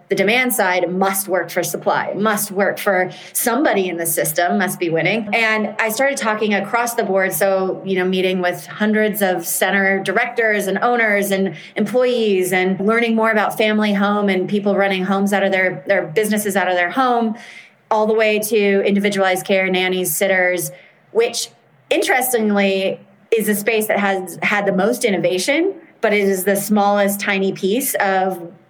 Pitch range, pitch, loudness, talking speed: 185-215 Hz, 200 Hz, -17 LUFS, 175 wpm